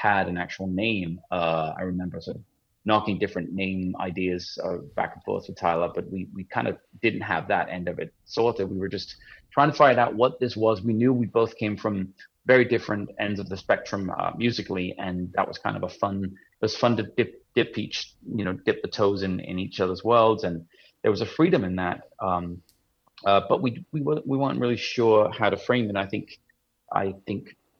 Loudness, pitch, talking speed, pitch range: -26 LUFS, 100 Hz, 225 wpm, 90-110 Hz